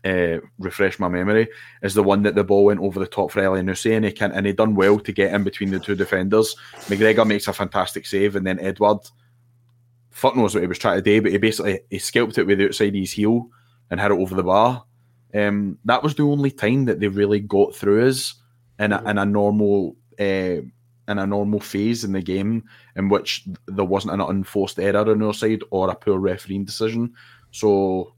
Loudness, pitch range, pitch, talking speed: -20 LUFS, 100-115 Hz, 105 Hz, 220 wpm